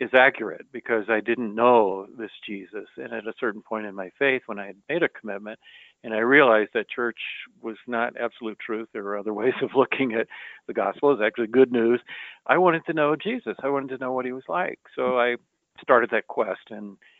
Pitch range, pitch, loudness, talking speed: 110-130 Hz, 120 Hz, -24 LUFS, 220 wpm